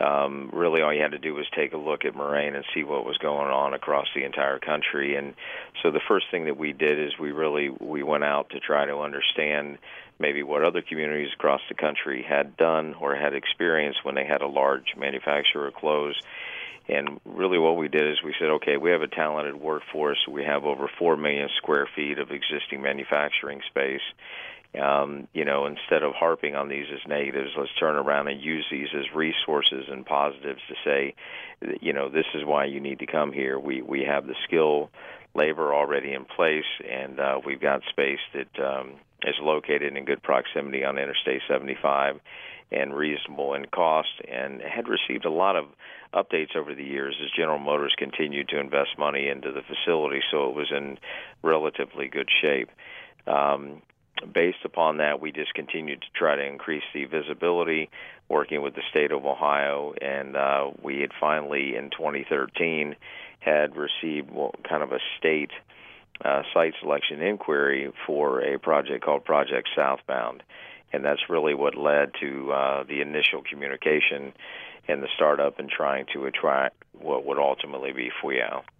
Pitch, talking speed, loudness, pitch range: 70 Hz, 180 wpm, -26 LUFS, 70-75 Hz